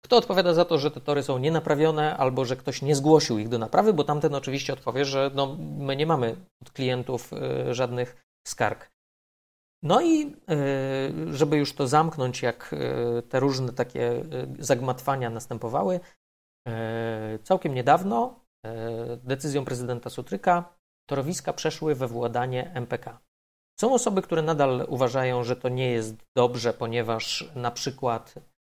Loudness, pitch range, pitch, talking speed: -26 LUFS, 120-155 Hz, 135 Hz, 135 wpm